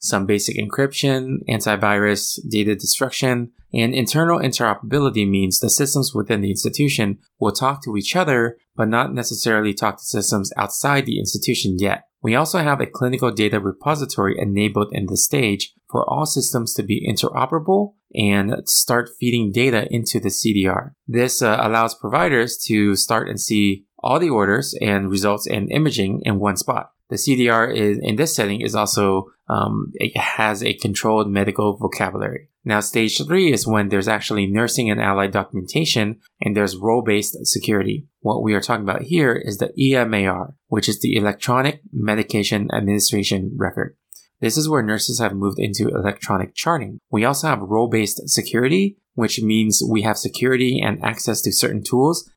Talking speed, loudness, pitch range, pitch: 165 wpm, -19 LUFS, 105-125 Hz, 110 Hz